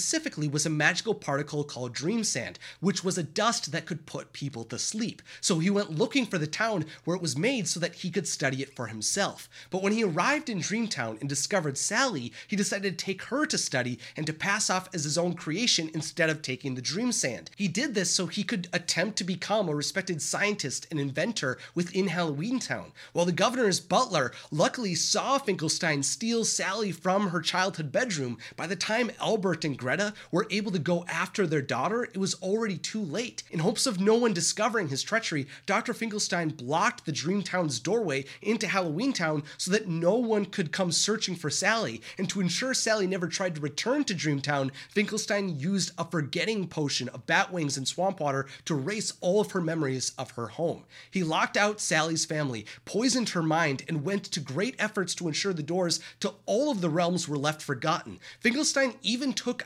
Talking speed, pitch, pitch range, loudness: 200 wpm, 180 Hz, 155-210 Hz, -28 LUFS